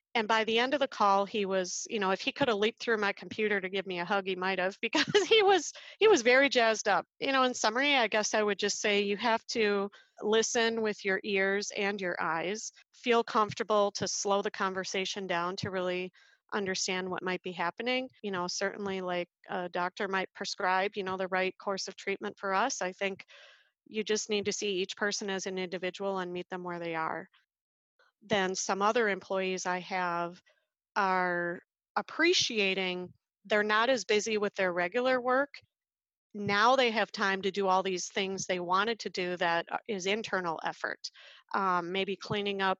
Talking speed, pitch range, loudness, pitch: 200 wpm, 185-225 Hz, -30 LUFS, 200 Hz